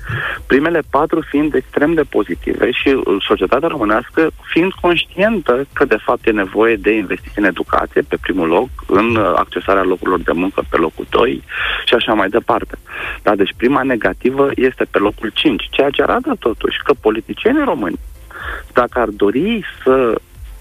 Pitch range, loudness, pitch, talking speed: 110-155 Hz, -15 LUFS, 130 Hz, 155 wpm